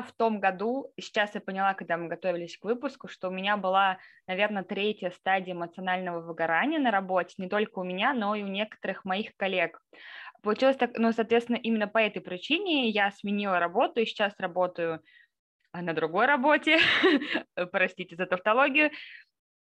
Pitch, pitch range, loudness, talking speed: 200 Hz, 185-230 Hz, -28 LUFS, 160 wpm